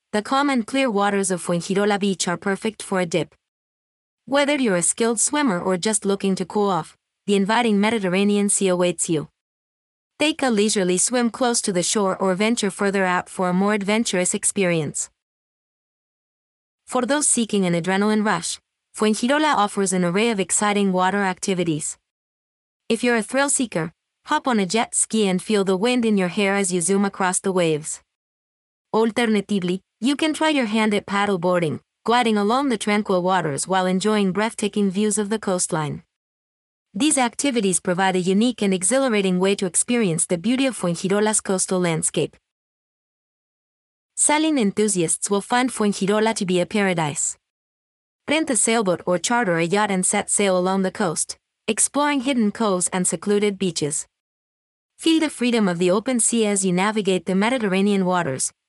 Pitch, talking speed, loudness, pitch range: 200 Hz, 165 wpm, -20 LUFS, 185-225 Hz